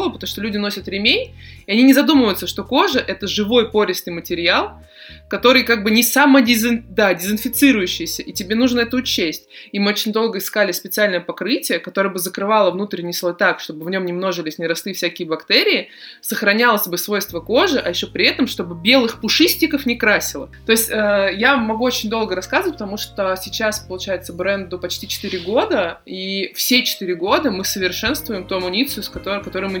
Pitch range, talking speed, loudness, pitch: 185-235 Hz, 180 wpm, -17 LUFS, 205 Hz